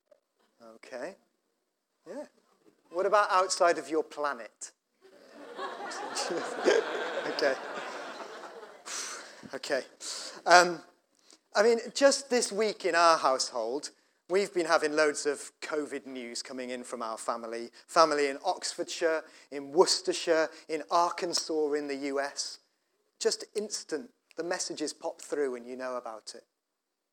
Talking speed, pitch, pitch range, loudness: 115 wpm, 165 Hz, 140-195 Hz, -30 LUFS